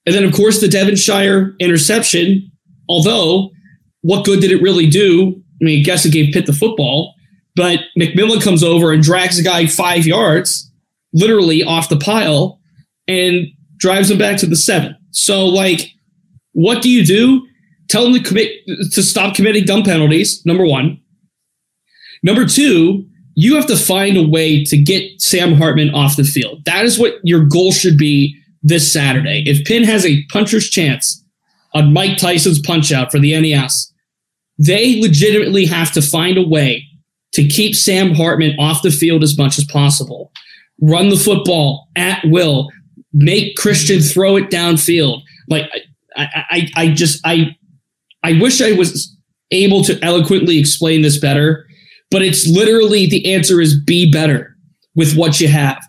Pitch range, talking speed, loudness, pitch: 155-190 Hz, 165 wpm, -12 LUFS, 170 Hz